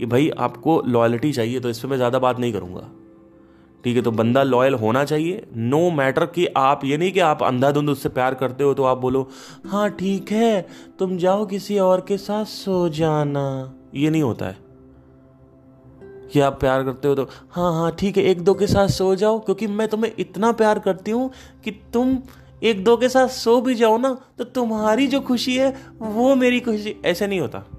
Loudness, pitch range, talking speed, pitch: -20 LUFS, 130-215 Hz, 205 wpm, 160 Hz